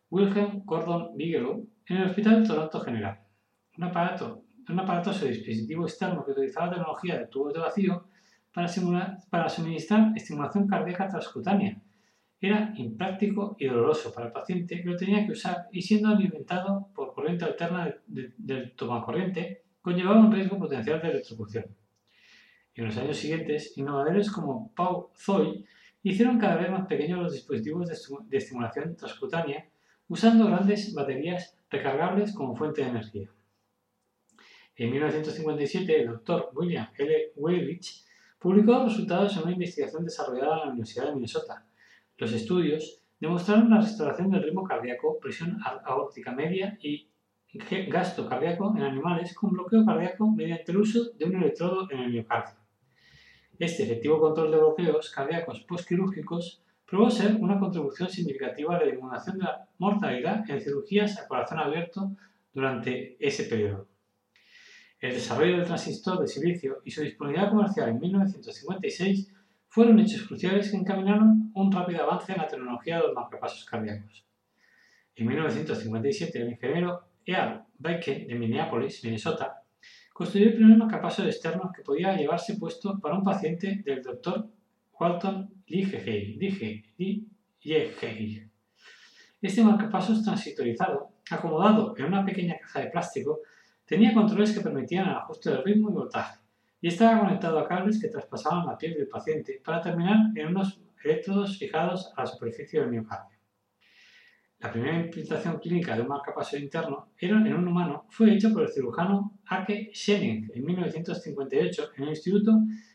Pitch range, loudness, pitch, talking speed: 155-210 Hz, -28 LUFS, 180 Hz, 150 wpm